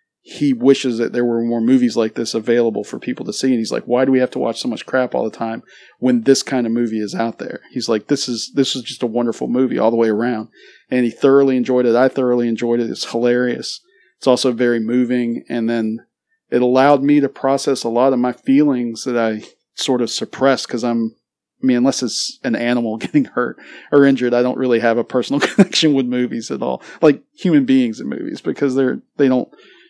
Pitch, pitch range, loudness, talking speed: 125 Hz, 120-135 Hz, -17 LUFS, 230 wpm